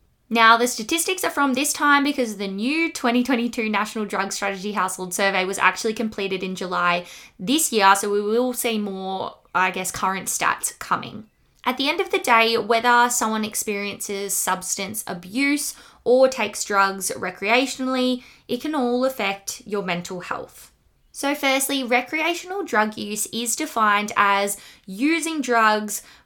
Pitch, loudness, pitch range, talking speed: 220 Hz, -21 LUFS, 195-255 Hz, 150 wpm